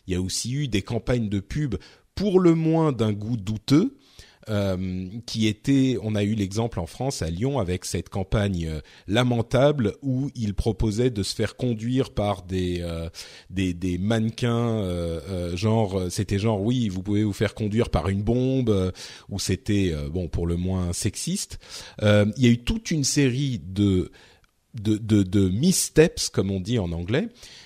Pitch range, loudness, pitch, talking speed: 95-120 Hz, -24 LUFS, 105 Hz, 180 wpm